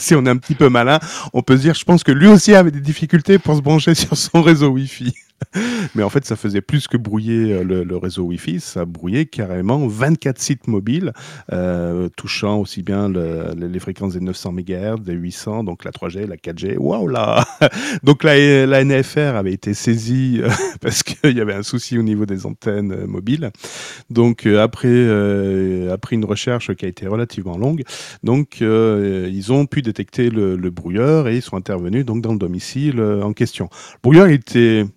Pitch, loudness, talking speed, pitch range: 115 Hz, -16 LUFS, 195 wpm, 100-145 Hz